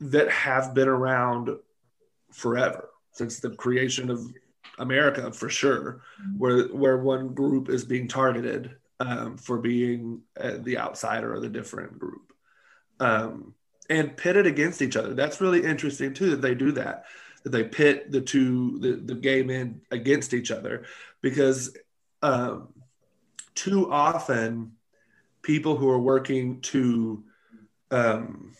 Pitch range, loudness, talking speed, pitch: 125-140 Hz, -26 LUFS, 140 wpm, 130 Hz